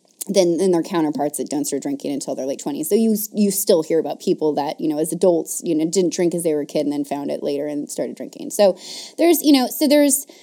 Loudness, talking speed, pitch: -20 LUFS, 270 wpm, 180 Hz